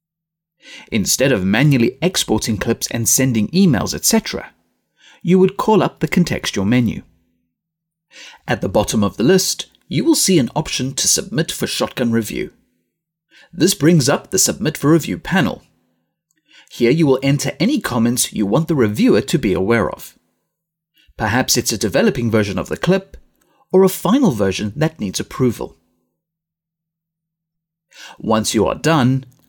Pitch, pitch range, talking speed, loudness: 160 Hz, 115-175 Hz, 150 wpm, -16 LUFS